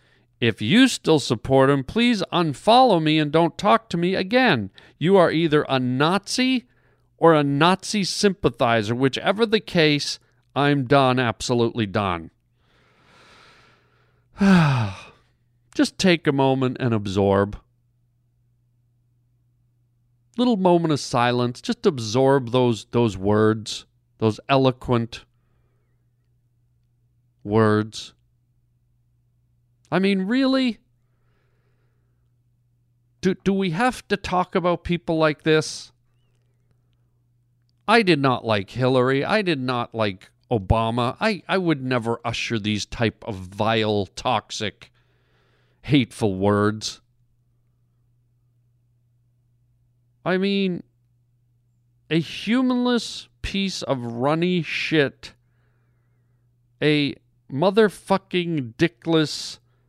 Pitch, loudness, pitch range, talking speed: 120 Hz, -21 LUFS, 120-160 Hz, 95 wpm